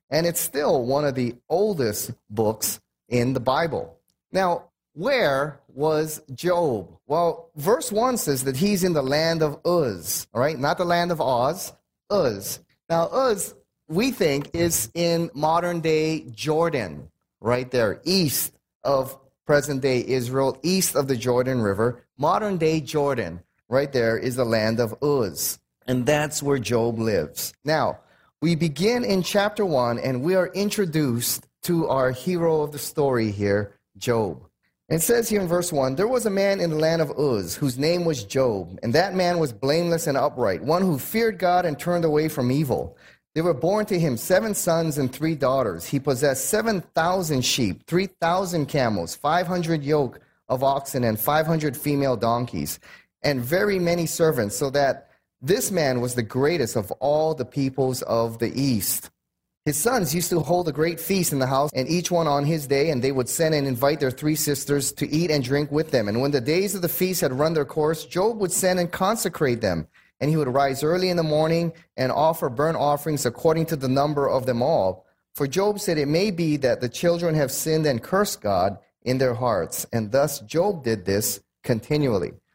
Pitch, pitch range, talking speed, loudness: 150 Hz, 130-170 Hz, 190 wpm, -23 LUFS